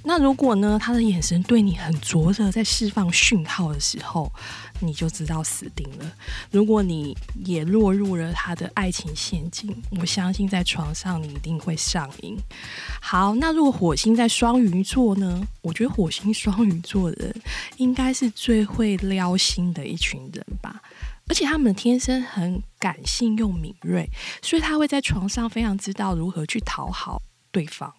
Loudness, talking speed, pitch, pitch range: -23 LUFS, 250 characters per minute, 195 Hz, 175-225 Hz